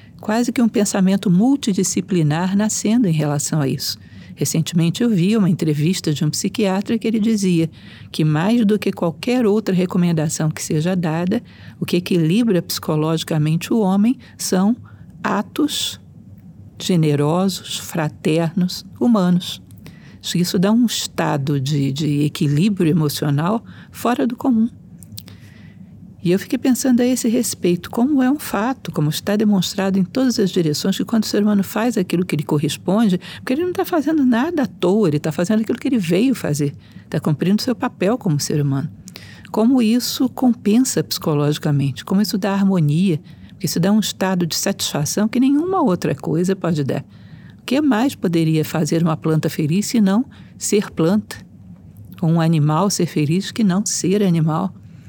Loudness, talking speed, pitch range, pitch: -18 LUFS, 160 wpm, 160-220 Hz, 185 Hz